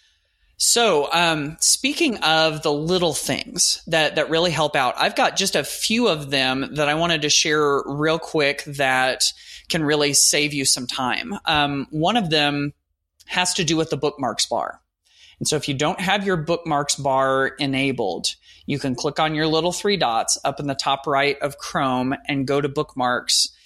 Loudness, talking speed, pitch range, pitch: -20 LUFS, 185 wpm, 140-165 Hz, 150 Hz